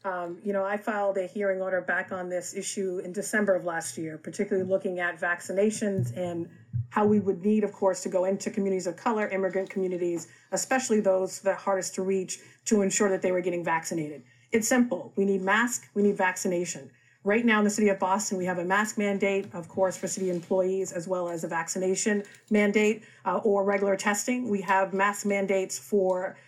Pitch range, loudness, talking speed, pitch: 180-205 Hz, -27 LUFS, 200 wpm, 190 Hz